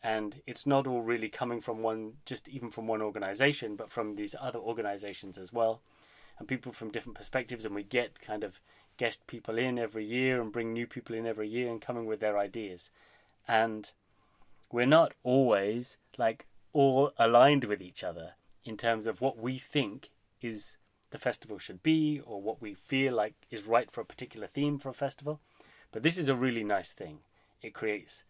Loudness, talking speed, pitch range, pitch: -32 LUFS, 195 wpm, 105-130 Hz, 115 Hz